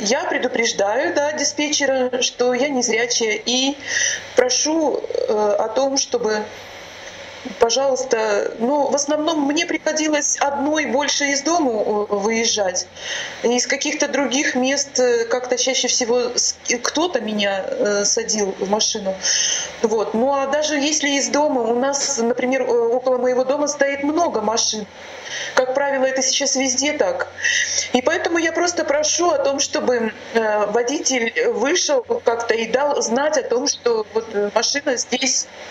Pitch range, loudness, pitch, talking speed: 235-290 Hz, -19 LUFS, 265 Hz, 135 wpm